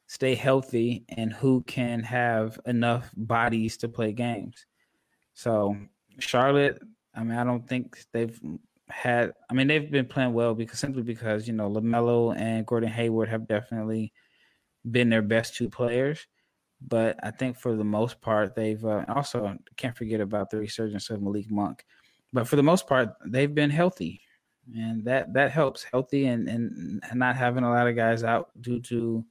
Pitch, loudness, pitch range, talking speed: 115 Hz, -27 LUFS, 110-125 Hz, 170 wpm